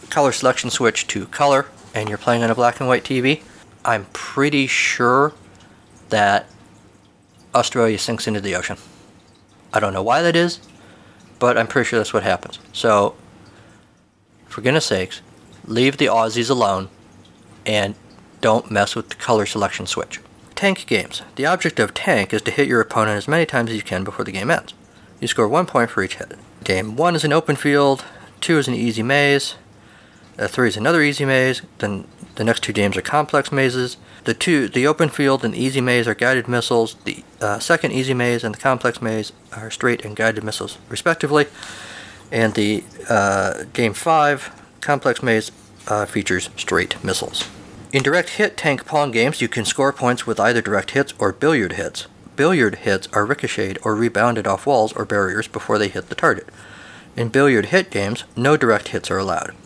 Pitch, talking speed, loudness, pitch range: 120 Hz, 185 wpm, -19 LUFS, 110-140 Hz